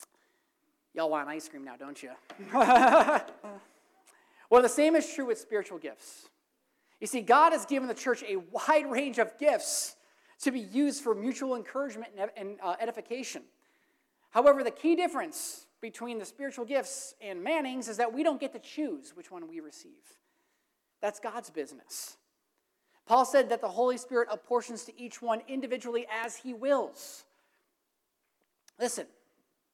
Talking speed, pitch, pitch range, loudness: 150 wpm, 265 Hz, 230-315 Hz, -29 LUFS